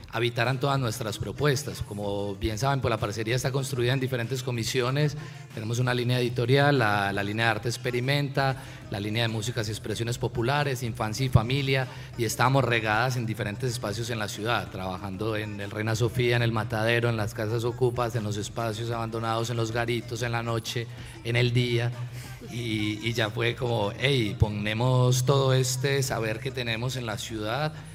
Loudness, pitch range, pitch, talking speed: -27 LUFS, 110-130 Hz, 120 Hz, 180 wpm